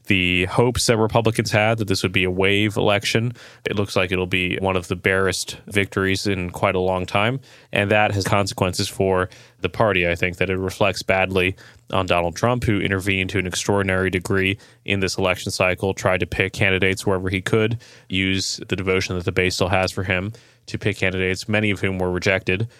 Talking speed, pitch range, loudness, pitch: 205 wpm, 95-105 Hz, -21 LUFS, 95 Hz